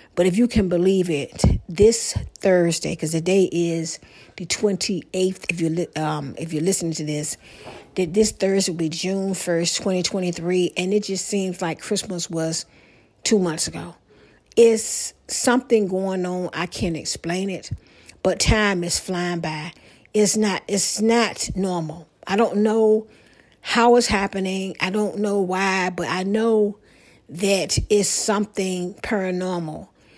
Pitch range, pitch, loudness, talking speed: 175-205 Hz, 185 Hz, -21 LUFS, 150 wpm